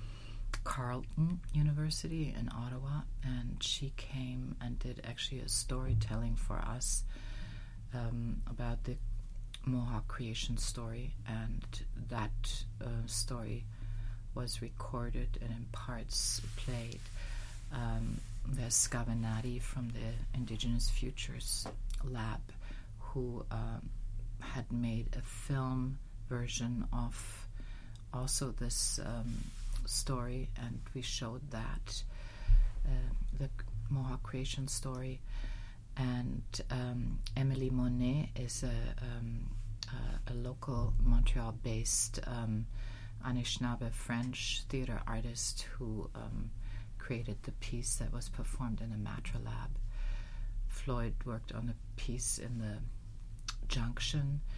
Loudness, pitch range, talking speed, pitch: -39 LUFS, 110-125 Hz, 105 wpm, 115 Hz